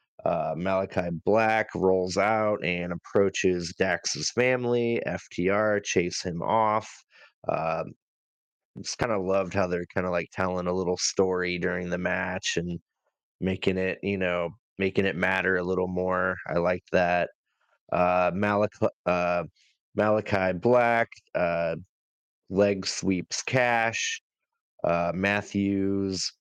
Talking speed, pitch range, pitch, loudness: 125 wpm, 90-105 Hz, 95 Hz, -27 LUFS